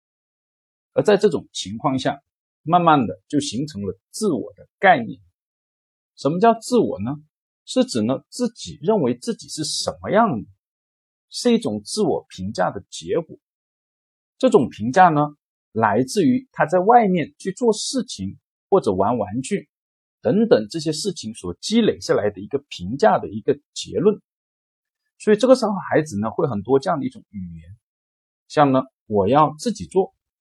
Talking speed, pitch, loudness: 230 characters per minute, 155 Hz, -20 LUFS